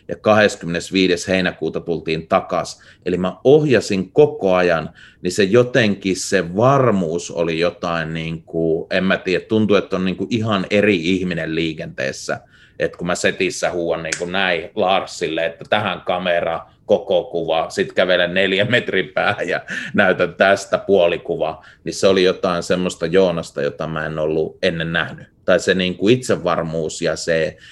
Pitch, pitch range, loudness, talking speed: 90 Hz, 80-95 Hz, -18 LUFS, 155 wpm